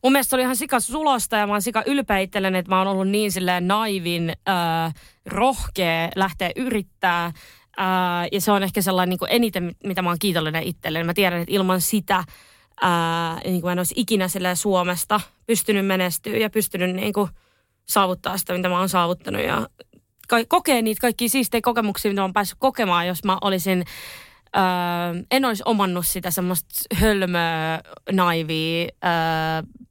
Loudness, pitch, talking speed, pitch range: -22 LUFS, 190 Hz, 160 wpm, 175-210 Hz